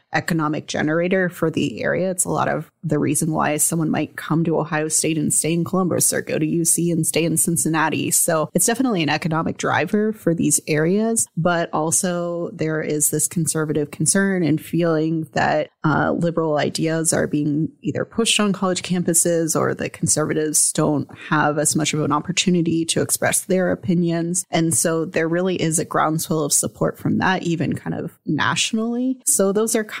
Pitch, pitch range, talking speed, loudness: 165 Hz, 155-180 Hz, 185 wpm, -19 LUFS